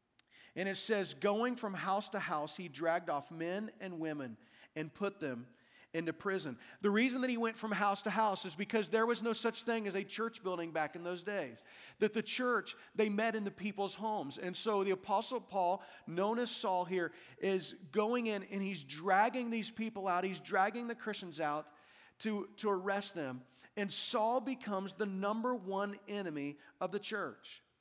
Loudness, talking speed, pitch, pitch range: -37 LUFS, 190 wpm, 200 Hz, 180-220 Hz